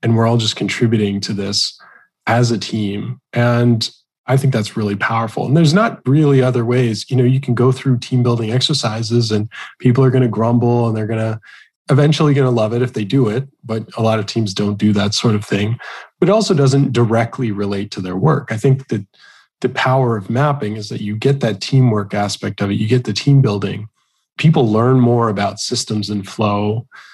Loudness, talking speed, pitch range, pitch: -16 LUFS, 215 wpm, 105-130 Hz, 115 Hz